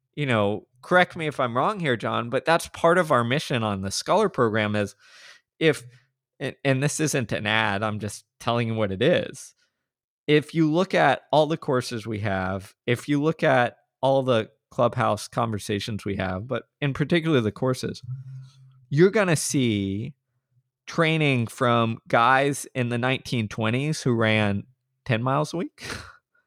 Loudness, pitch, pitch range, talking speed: -24 LUFS, 130 Hz, 110-150 Hz, 170 wpm